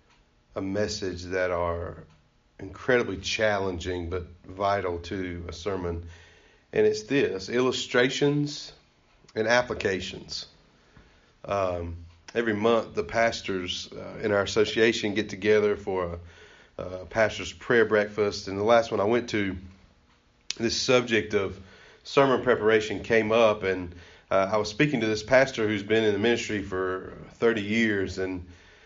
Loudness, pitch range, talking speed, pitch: -26 LUFS, 90-115 Hz, 135 wpm, 100 Hz